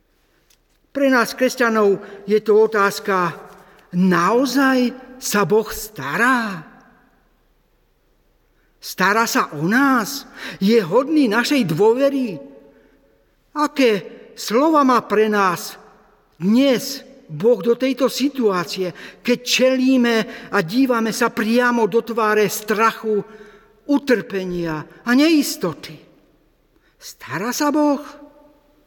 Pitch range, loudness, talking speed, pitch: 205-260 Hz, -18 LUFS, 90 wpm, 235 Hz